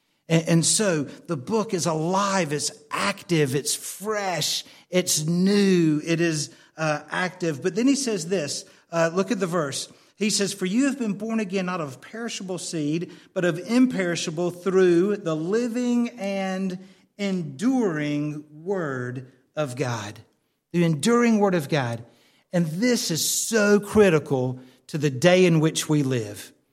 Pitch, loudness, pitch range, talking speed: 175 Hz, -24 LUFS, 150-200 Hz, 150 wpm